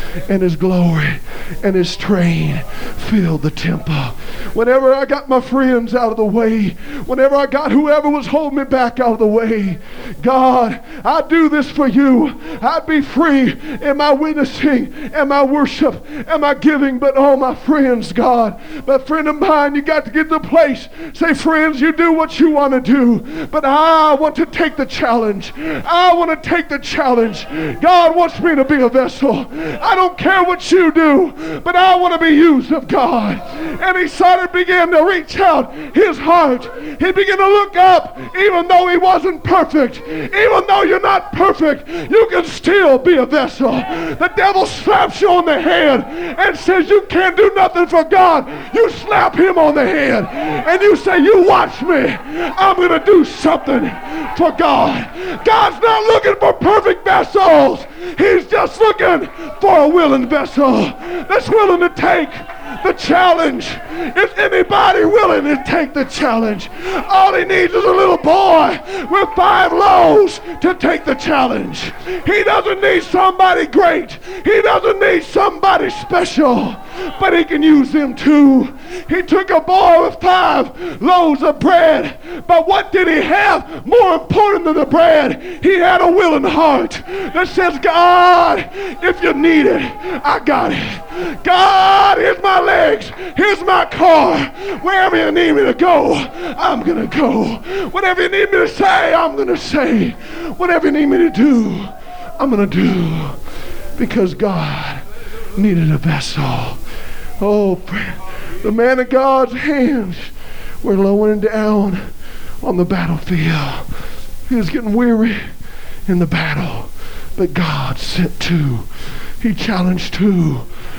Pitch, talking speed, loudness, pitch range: 315 Hz, 160 wpm, -13 LUFS, 255-365 Hz